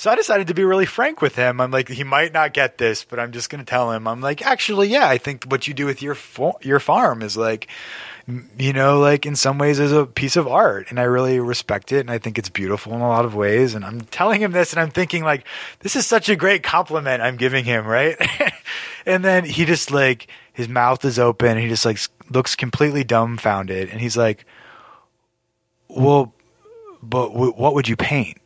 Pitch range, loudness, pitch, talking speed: 120-150 Hz, -19 LUFS, 135 Hz, 230 wpm